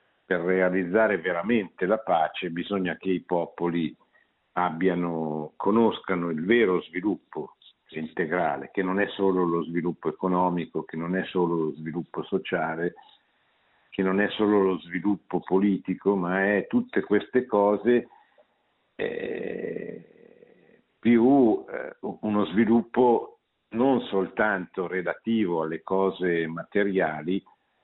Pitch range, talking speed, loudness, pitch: 85-105 Hz, 110 wpm, -26 LUFS, 95 Hz